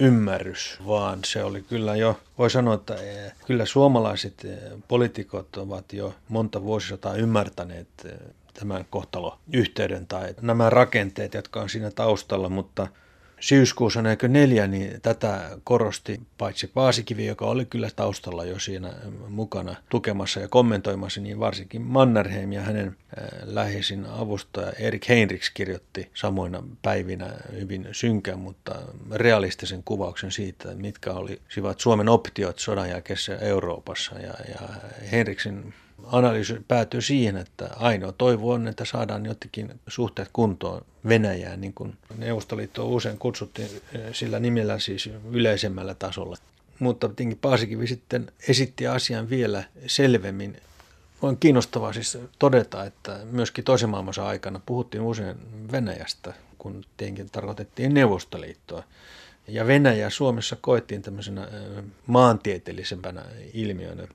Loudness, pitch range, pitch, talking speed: -25 LUFS, 100-120 Hz, 110 Hz, 120 wpm